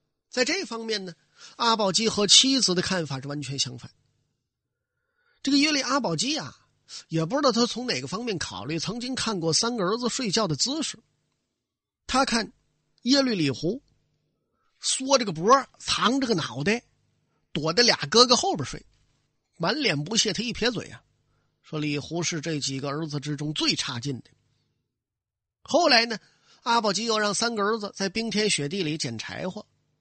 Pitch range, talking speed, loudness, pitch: 145-235 Hz, 240 characters per minute, -24 LUFS, 190 Hz